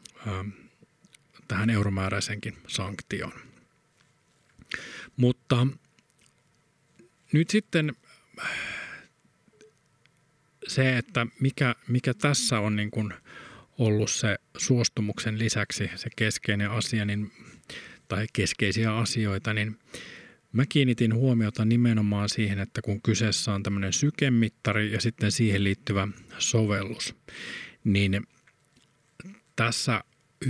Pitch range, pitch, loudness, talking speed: 105-145 Hz, 115 Hz, -27 LUFS, 85 wpm